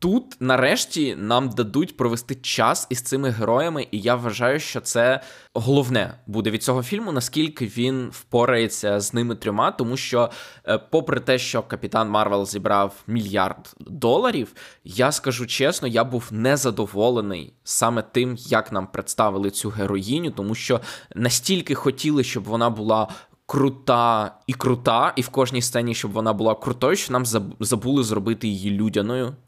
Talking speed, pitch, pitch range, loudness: 145 wpm, 120 Hz, 110-130 Hz, -22 LUFS